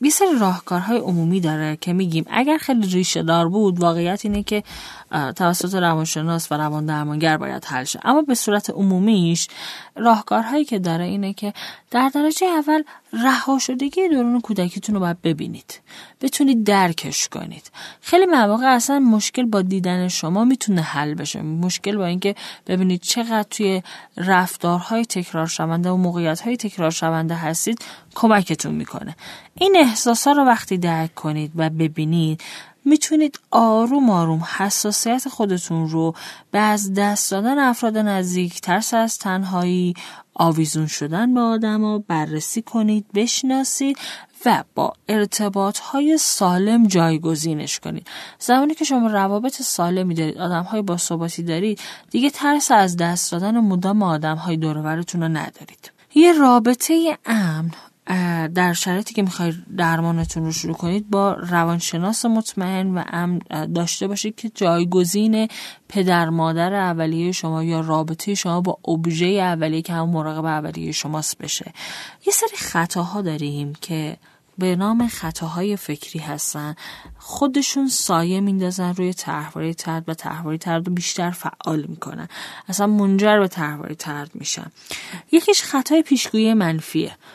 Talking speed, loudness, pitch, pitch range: 135 wpm, -20 LUFS, 185 Hz, 165-225 Hz